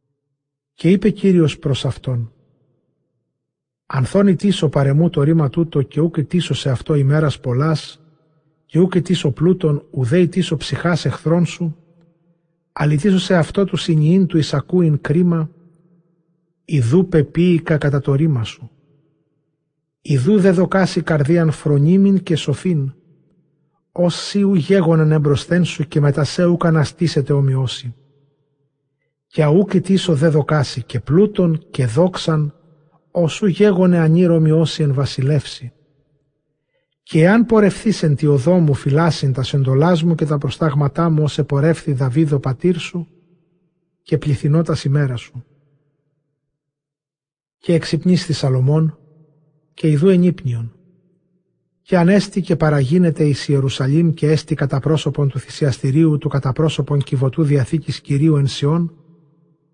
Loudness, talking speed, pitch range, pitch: -16 LUFS, 125 wpm, 145-170 Hz, 155 Hz